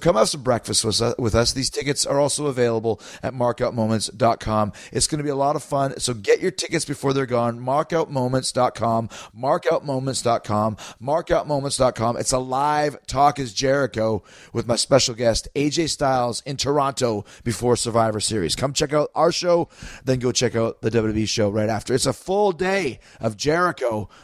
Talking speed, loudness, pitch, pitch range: 170 wpm, -22 LUFS, 130 Hz, 115-145 Hz